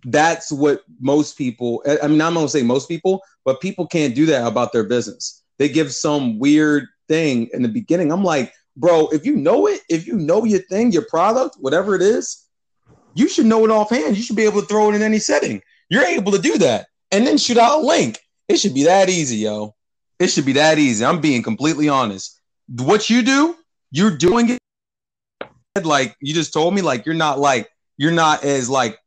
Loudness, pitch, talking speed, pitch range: -17 LUFS, 160 Hz, 215 wpm, 140-215 Hz